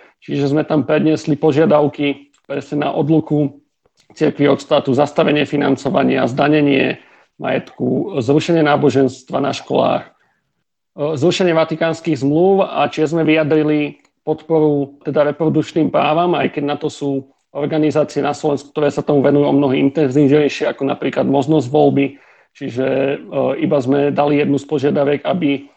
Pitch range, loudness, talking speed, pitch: 140-155 Hz, -16 LUFS, 135 wpm, 145 Hz